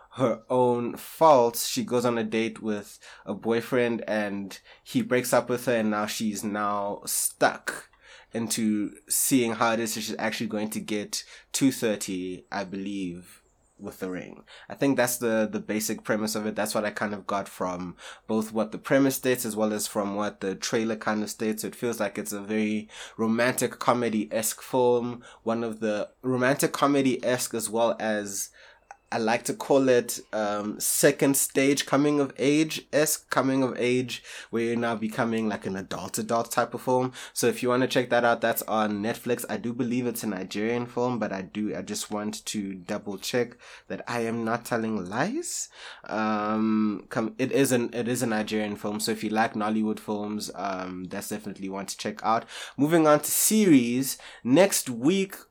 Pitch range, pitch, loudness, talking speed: 105-125 Hz, 115 Hz, -27 LUFS, 190 wpm